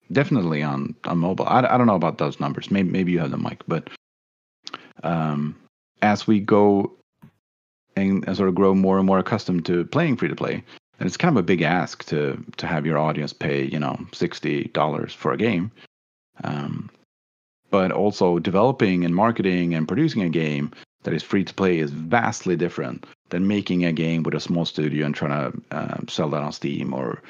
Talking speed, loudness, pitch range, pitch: 200 wpm, -22 LUFS, 75-95 Hz, 85 Hz